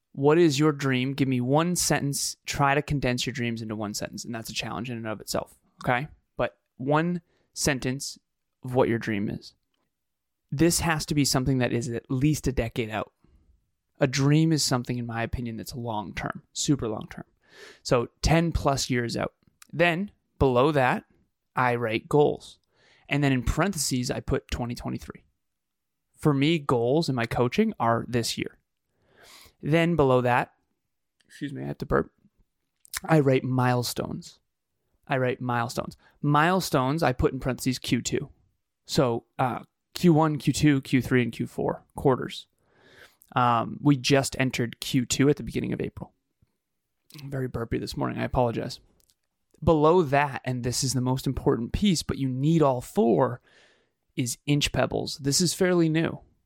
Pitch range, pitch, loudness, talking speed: 120-150 Hz, 130 Hz, -26 LUFS, 160 wpm